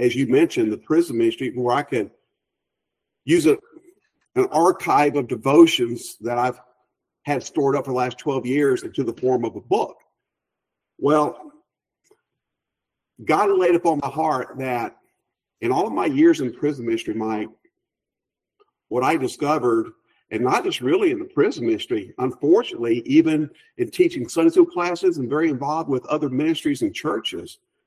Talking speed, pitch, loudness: 155 wpm, 325 Hz, -21 LUFS